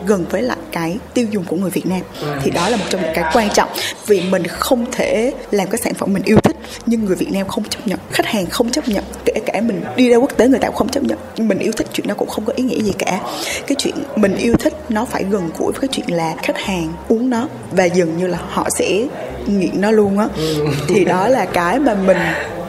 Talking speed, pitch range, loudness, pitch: 265 wpm, 180-250 Hz, -17 LUFS, 210 Hz